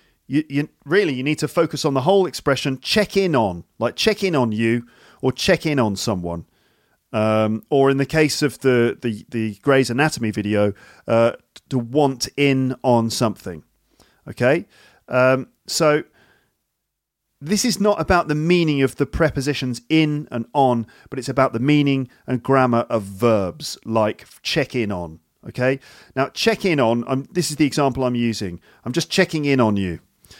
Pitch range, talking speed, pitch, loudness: 115-150 Hz, 175 wpm, 130 Hz, -20 LUFS